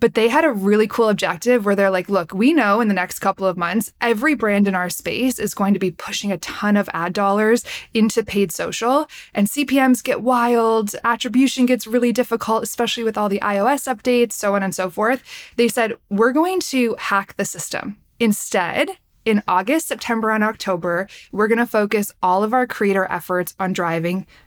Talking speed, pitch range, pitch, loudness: 200 wpm, 200-245 Hz, 220 Hz, -19 LUFS